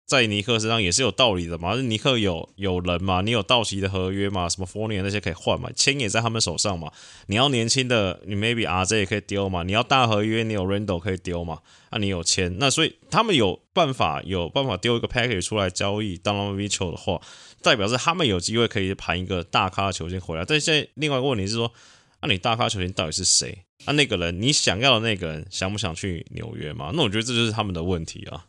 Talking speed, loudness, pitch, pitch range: 420 characters per minute, -23 LUFS, 100 Hz, 95-115 Hz